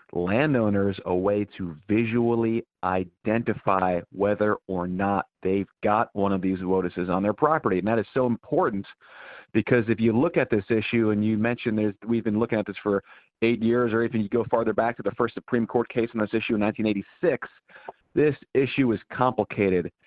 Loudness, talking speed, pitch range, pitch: -25 LUFS, 185 wpm, 100-115 Hz, 110 Hz